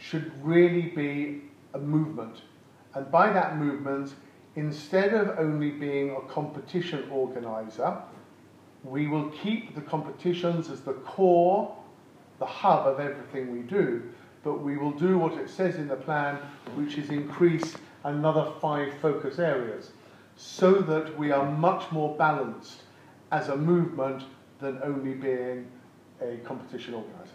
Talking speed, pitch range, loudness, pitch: 140 wpm, 140-165 Hz, -28 LUFS, 150 Hz